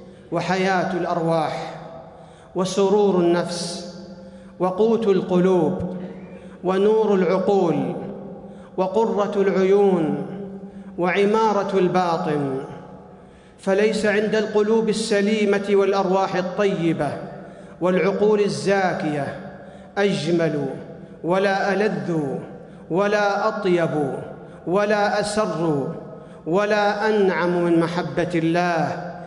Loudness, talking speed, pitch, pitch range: -21 LUFS, 65 wpm, 185 Hz, 170-200 Hz